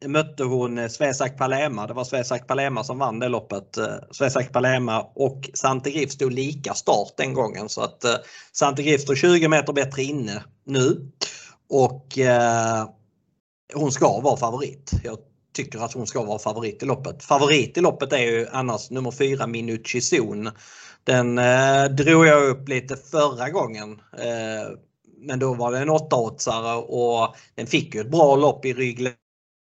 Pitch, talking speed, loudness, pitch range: 130 Hz, 155 wpm, -22 LUFS, 115-140 Hz